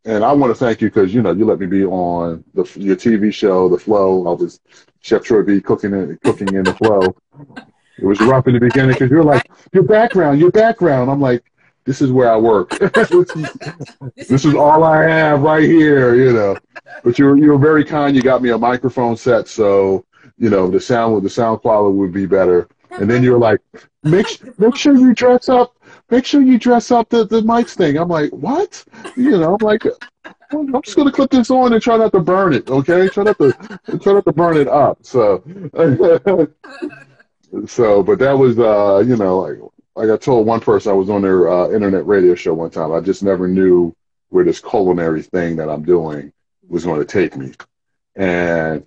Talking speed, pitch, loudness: 210 wpm, 135 Hz, -13 LUFS